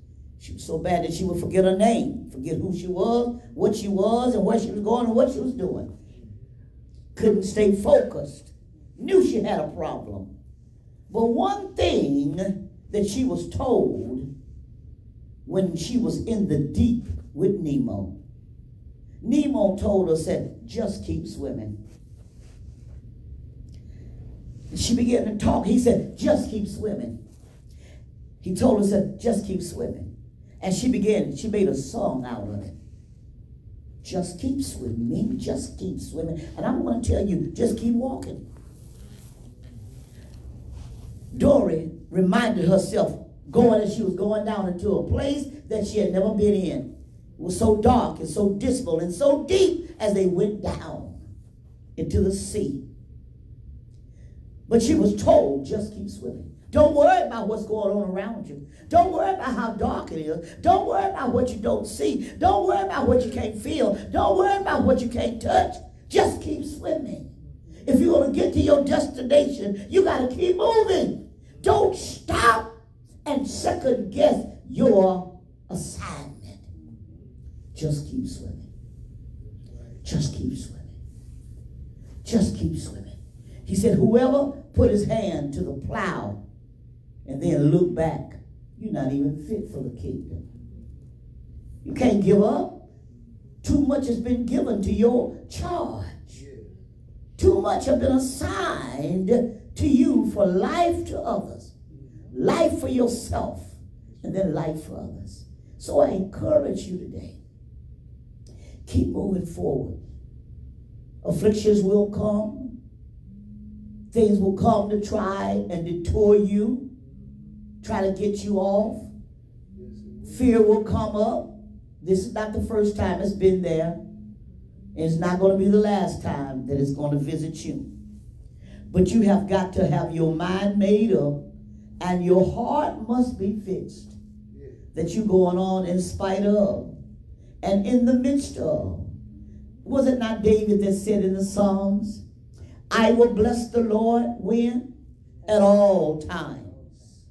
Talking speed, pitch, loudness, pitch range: 145 wpm, 200 Hz, -23 LUFS, 155-235 Hz